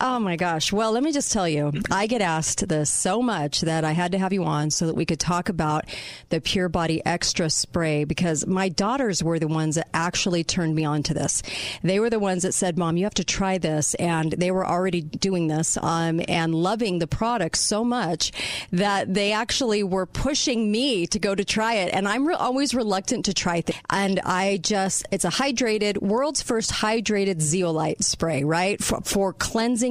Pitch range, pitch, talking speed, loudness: 165-215 Hz, 185 Hz, 215 wpm, -23 LUFS